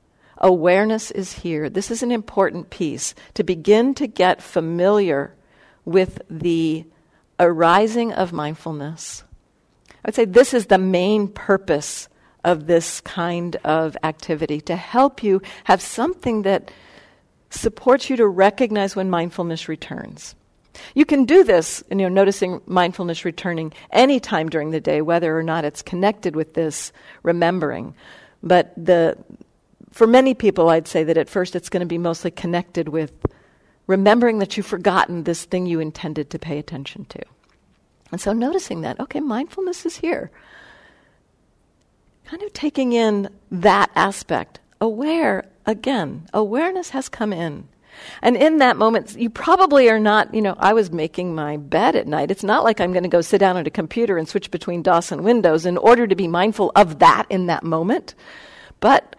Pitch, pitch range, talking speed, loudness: 190 Hz, 170-225 Hz, 165 wpm, -19 LUFS